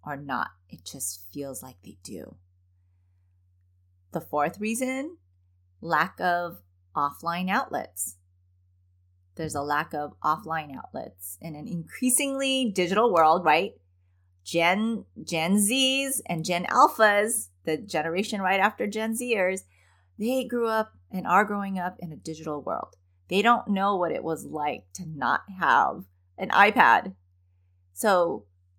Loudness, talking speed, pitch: -25 LUFS, 130 wpm, 155 Hz